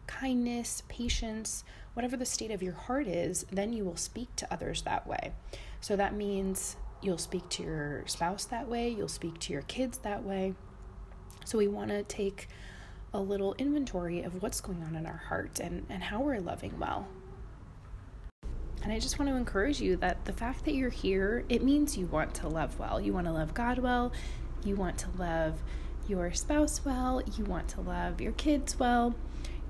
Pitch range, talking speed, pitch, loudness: 175-240 Hz, 190 wpm, 200 Hz, -34 LUFS